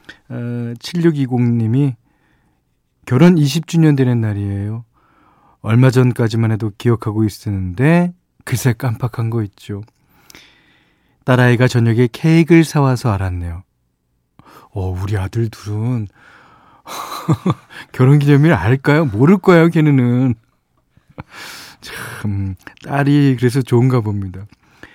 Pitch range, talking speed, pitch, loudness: 105-140 Hz, 215 characters per minute, 120 Hz, -15 LUFS